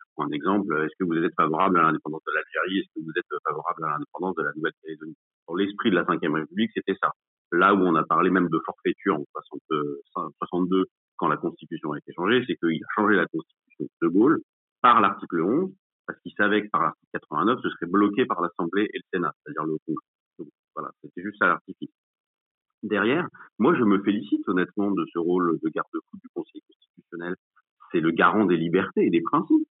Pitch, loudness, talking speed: 185 Hz, -25 LUFS, 205 wpm